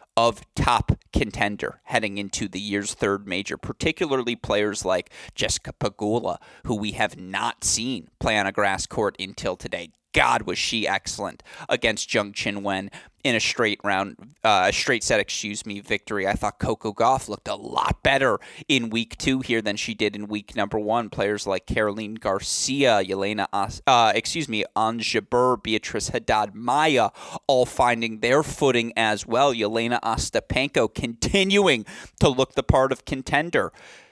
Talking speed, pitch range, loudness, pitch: 160 wpm, 105-125 Hz, -23 LUFS, 115 Hz